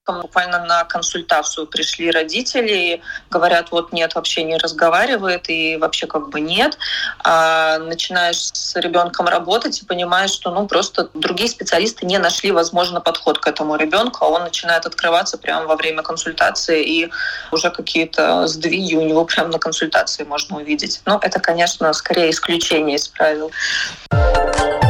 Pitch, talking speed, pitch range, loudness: 170 Hz, 145 wpm, 160-175 Hz, -17 LUFS